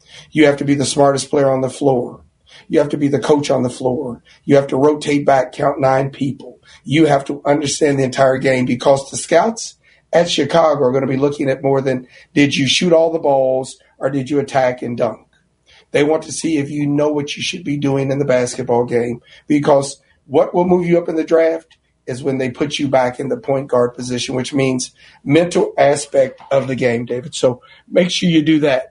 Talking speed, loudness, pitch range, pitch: 225 wpm, -16 LUFS, 130-150 Hz, 140 Hz